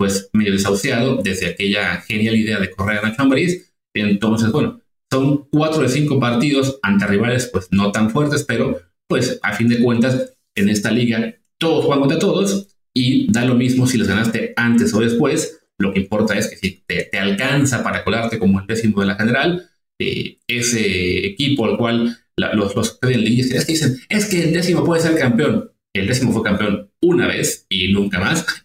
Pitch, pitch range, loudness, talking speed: 115 Hz, 100-135 Hz, -17 LUFS, 190 wpm